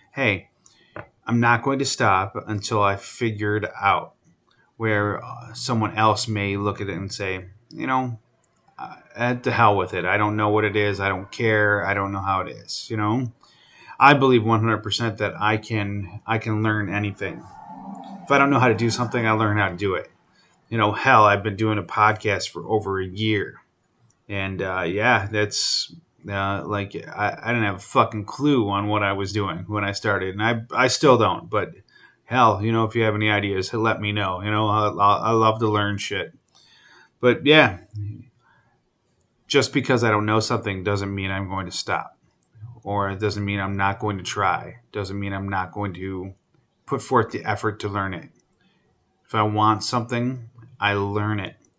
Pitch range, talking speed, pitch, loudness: 100-115 Hz, 195 wpm, 105 Hz, -22 LUFS